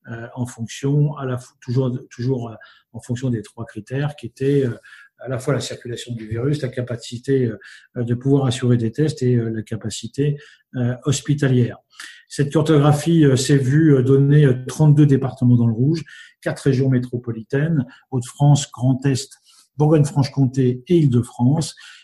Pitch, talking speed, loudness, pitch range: 130 Hz, 135 wpm, -19 LUFS, 120-145 Hz